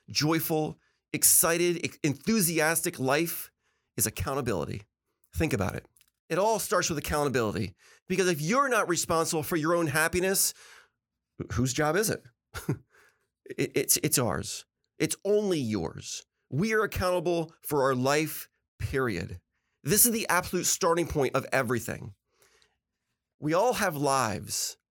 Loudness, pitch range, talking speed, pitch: -27 LUFS, 130-180 Hz, 130 wpm, 160 Hz